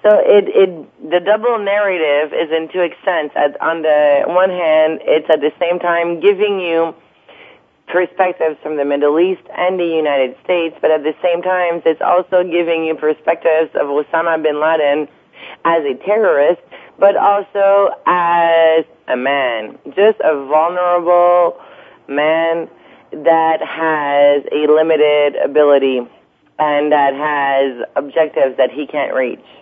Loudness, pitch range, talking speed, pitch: -14 LUFS, 150-180 Hz, 140 wpm, 160 Hz